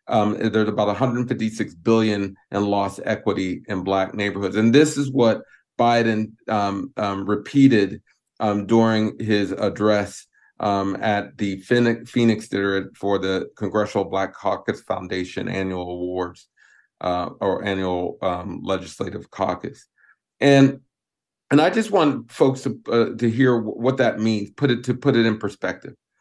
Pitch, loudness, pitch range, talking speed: 105 Hz, -21 LUFS, 100-115 Hz, 145 wpm